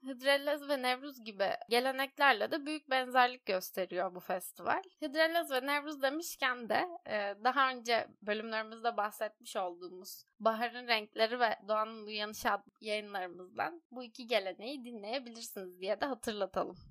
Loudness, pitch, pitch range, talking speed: -35 LUFS, 235 Hz, 210-270 Hz, 125 wpm